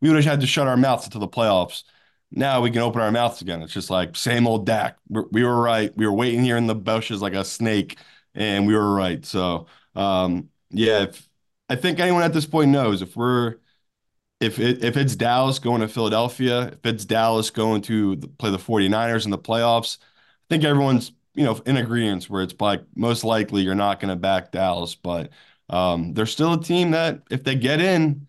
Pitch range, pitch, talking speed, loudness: 100-130 Hz, 115 Hz, 215 wpm, -22 LUFS